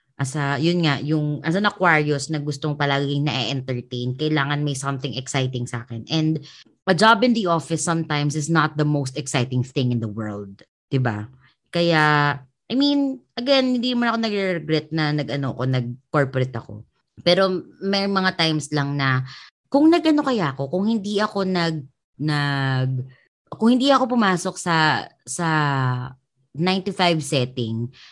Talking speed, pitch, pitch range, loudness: 150 wpm, 150 Hz, 135-180 Hz, -21 LUFS